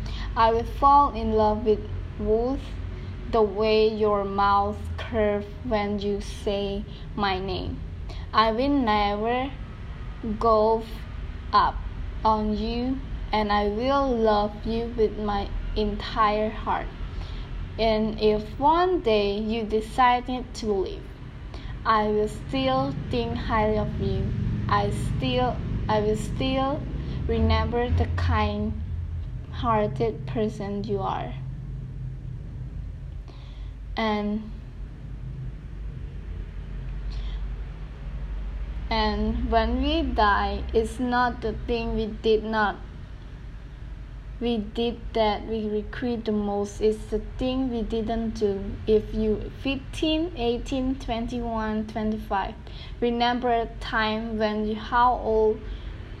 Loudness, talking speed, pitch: -26 LUFS, 105 wpm, 215 Hz